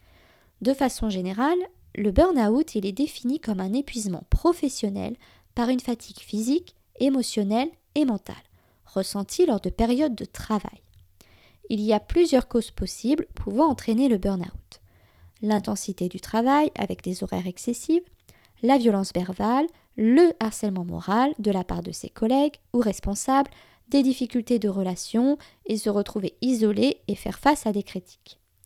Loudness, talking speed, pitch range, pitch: -25 LUFS, 145 wpm, 200-265 Hz, 225 Hz